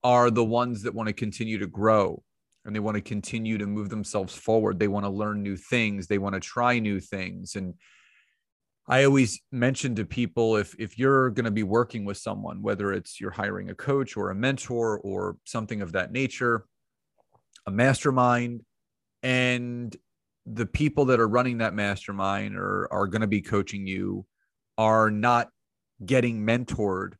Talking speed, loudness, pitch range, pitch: 175 wpm, -26 LUFS, 100-120 Hz, 110 Hz